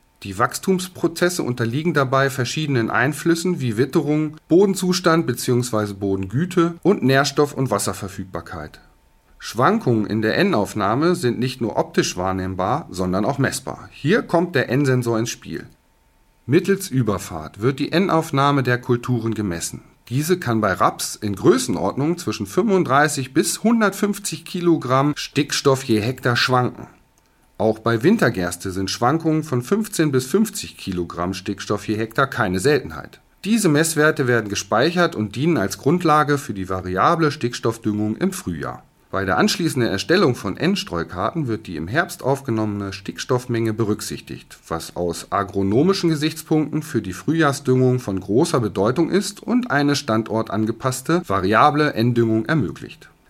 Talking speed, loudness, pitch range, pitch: 130 wpm, -20 LUFS, 105-160 Hz, 125 Hz